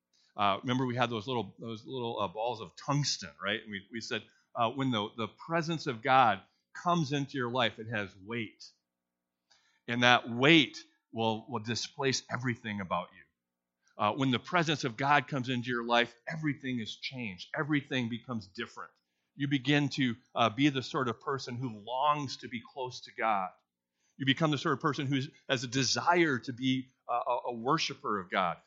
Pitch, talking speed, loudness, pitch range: 125 Hz, 190 wpm, -32 LUFS, 110-140 Hz